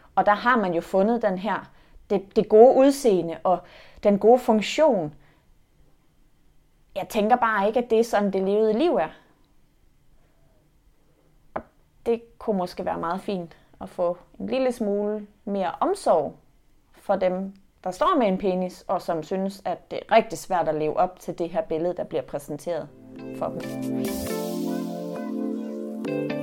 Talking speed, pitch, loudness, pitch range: 155 wpm, 195 Hz, -24 LUFS, 170-220 Hz